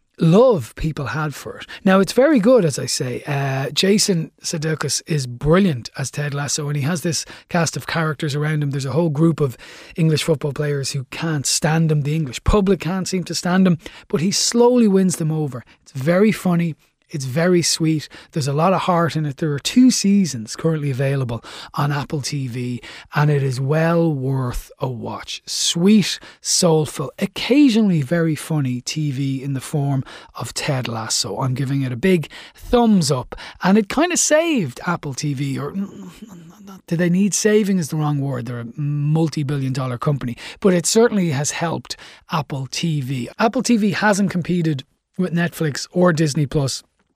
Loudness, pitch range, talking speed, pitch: -19 LUFS, 140-185 Hz, 175 wpm, 160 Hz